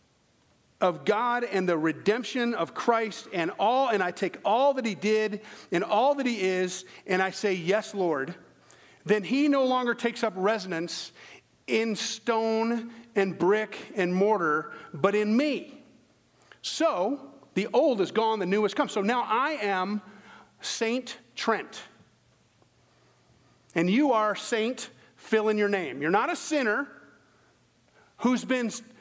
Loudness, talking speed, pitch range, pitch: -27 LUFS, 145 wpm, 190-235 Hz, 215 Hz